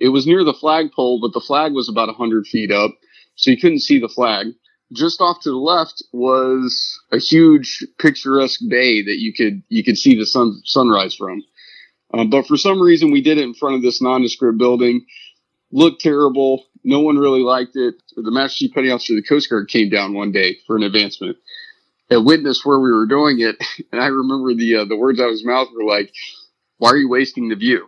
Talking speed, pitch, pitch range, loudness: 220 wpm, 135 Hz, 120-170 Hz, -15 LUFS